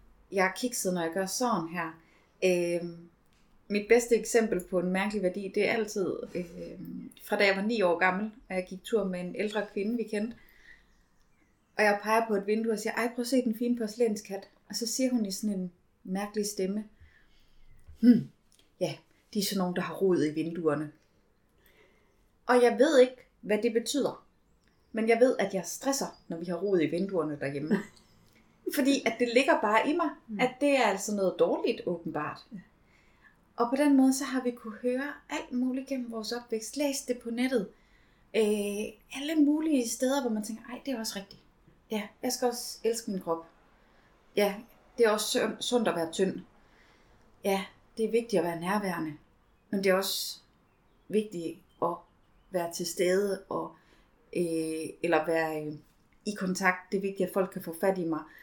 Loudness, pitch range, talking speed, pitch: -30 LUFS, 185-240 Hz, 190 wpm, 210 Hz